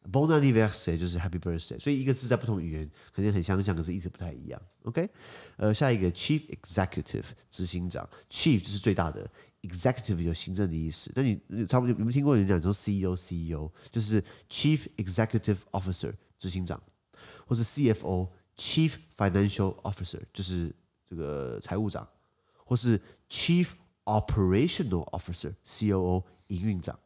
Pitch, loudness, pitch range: 100 Hz, -30 LUFS, 90-115 Hz